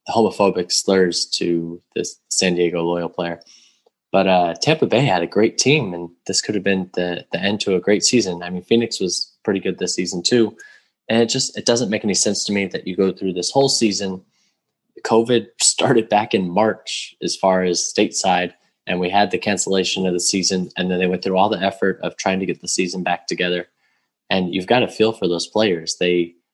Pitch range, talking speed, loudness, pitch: 90-105 Hz, 215 wpm, -19 LUFS, 95 Hz